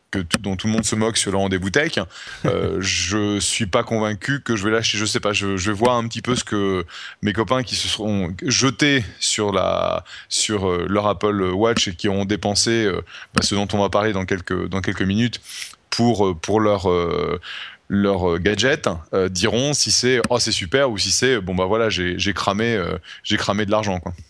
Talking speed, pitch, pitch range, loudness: 220 wpm, 105 Hz, 95-115 Hz, -20 LUFS